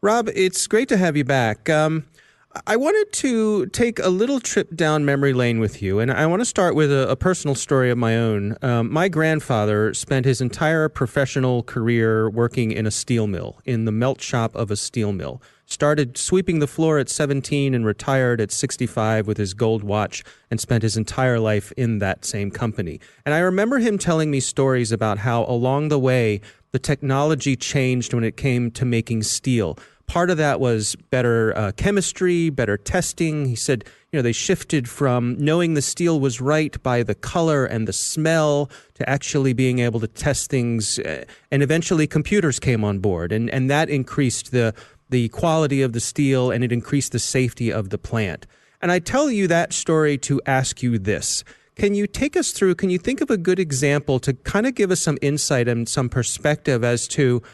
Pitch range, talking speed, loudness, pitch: 115-155 Hz, 200 wpm, -21 LUFS, 130 Hz